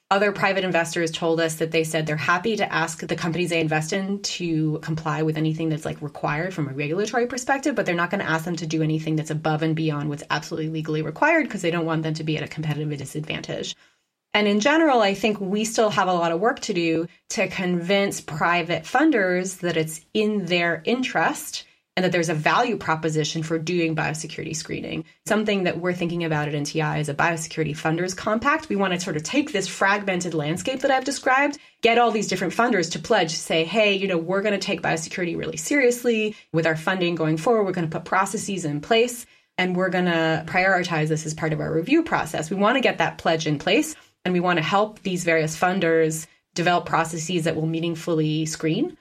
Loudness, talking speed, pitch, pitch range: -23 LUFS, 220 wpm, 170 Hz, 160-200 Hz